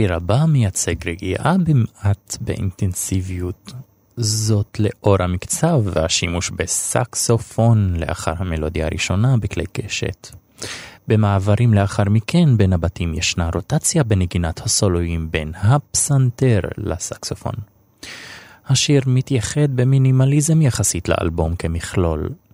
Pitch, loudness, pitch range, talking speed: 100 Hz, -18 LUFS, 85-125 Hz, 90 wpm